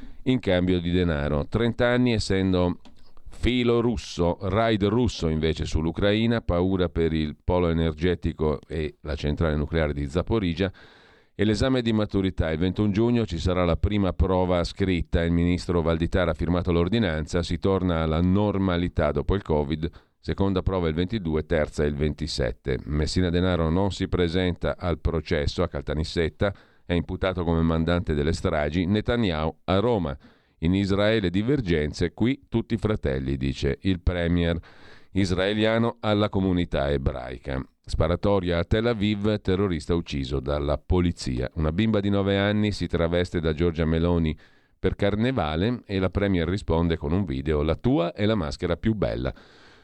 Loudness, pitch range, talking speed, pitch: -25 LUFS, 80-100 Hz, 150 wpm, 90 Hz